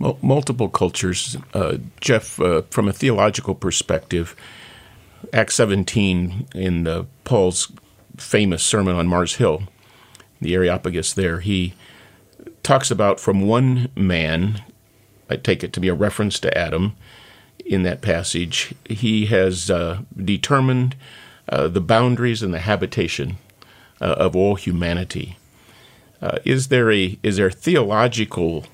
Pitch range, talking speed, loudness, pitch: 90-110 Hz, 130 wpm, -20 LUFS, 100 Hz